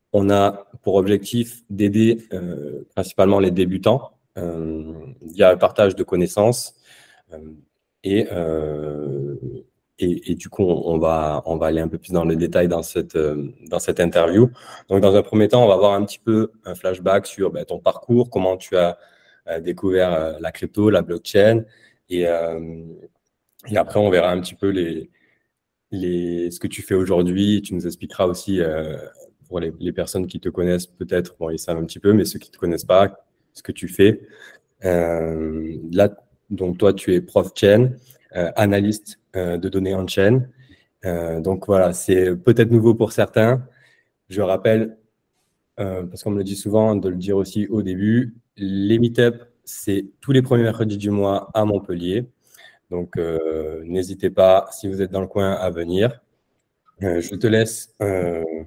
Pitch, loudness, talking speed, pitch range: 95 Hz, -20 LUFS, 185 wpm, 85-105 Hz